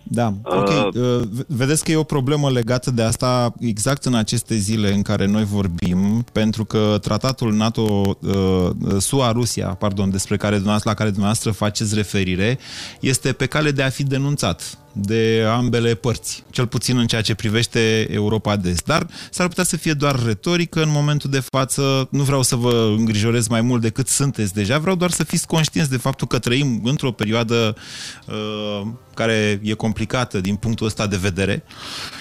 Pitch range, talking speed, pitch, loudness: 105-135 Hz, 170 wpm, 115 Hz, -19 LUFS